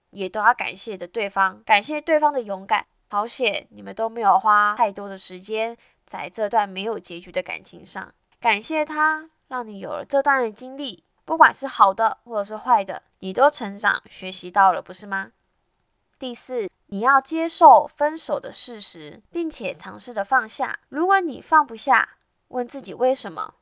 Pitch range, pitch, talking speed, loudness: 200-290 Hz, 235 Hz, 260 characters per minute, -20 LUFS